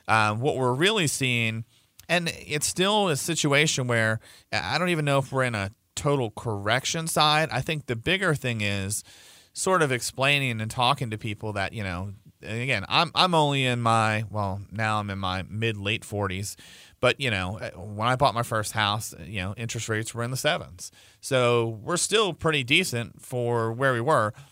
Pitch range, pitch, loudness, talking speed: 105-145 Hz, 120 Hz, -25 LUFS, 190 wpm